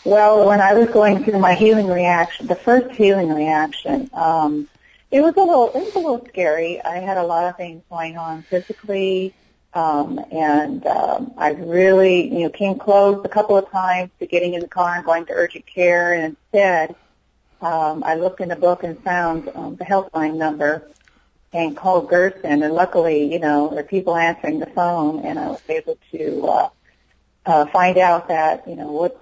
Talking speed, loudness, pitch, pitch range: 190 wpm, -18 LUFS, 175 Hz, 160-195 Hz